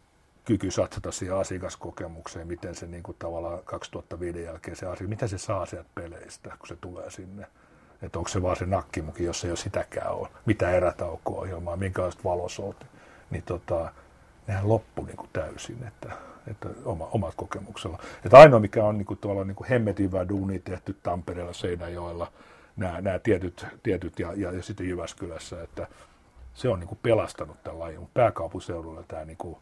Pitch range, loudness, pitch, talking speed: 85-100 Hz, -26 LUFS, 90 Hz, 160 wpm